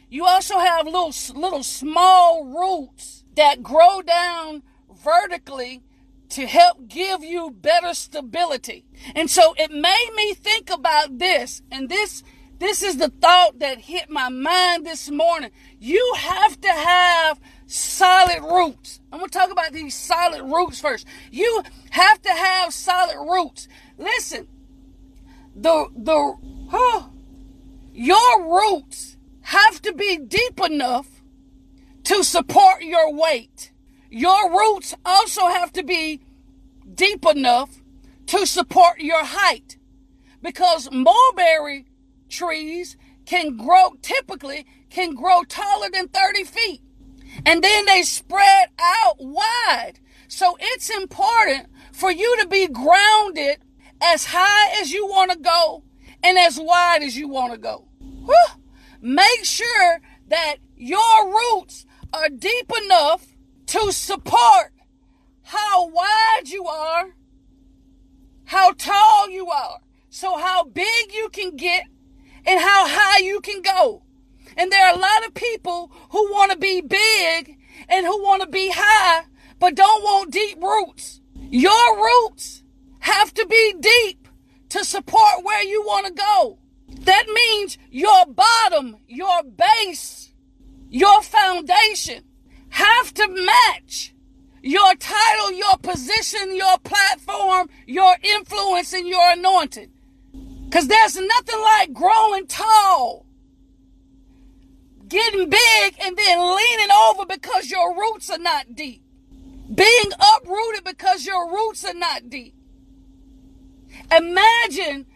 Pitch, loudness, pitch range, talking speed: 360 Hz, -17 LUFS, 290-395 Hz, 125 wpm